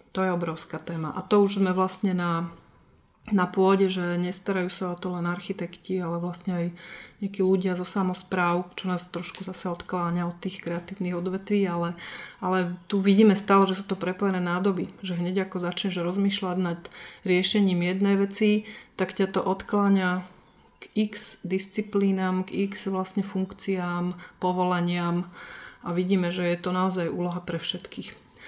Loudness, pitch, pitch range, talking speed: -26 LUFS, 185 Hz, 175-195 Hz, 160 wpm